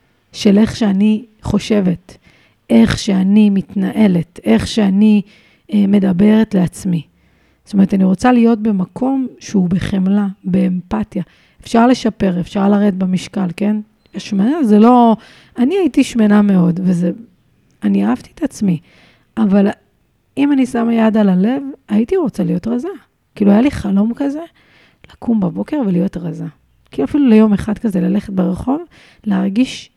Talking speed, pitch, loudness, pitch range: 135 wpm, 205 Hz, -14 LUFS, 185-230 Hz